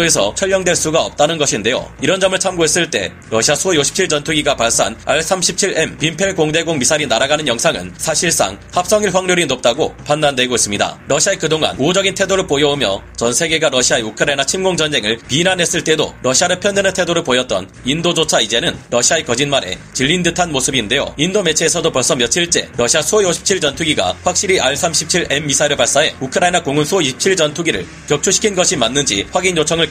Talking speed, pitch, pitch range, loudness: 415 characters per minute, 160 Hz, 140-180 Hz, -14 LUFS